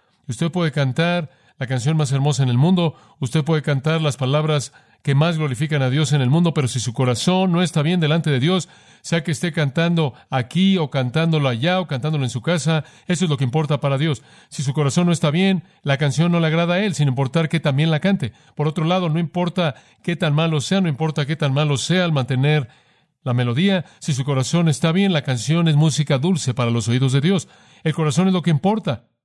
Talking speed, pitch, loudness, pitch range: 230 wpm, 155 Hz, -19 LUFS, 140-170 Hz